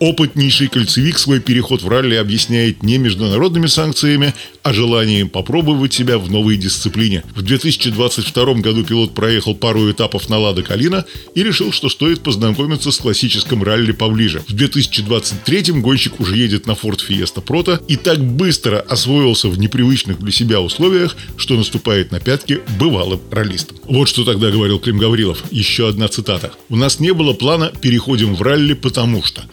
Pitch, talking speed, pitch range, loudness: 120 Hz, 160 wpm, 110-140 Hz, -14 LUFS